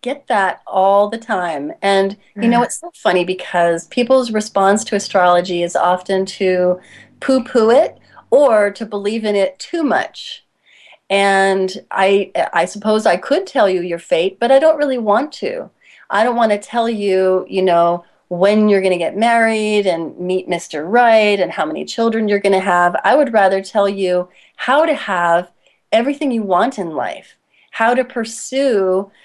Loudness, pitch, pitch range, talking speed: -15 LUFS, 200 Hz, 185-235 Hz, 175 wpm